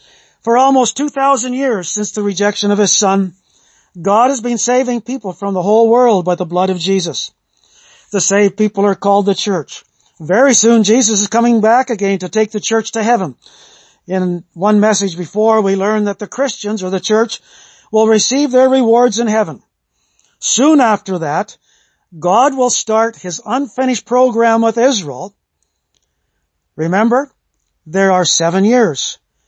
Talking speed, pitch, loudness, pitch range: 160 wpm, 210 Hz, -13 LUFS, 185-235 Hz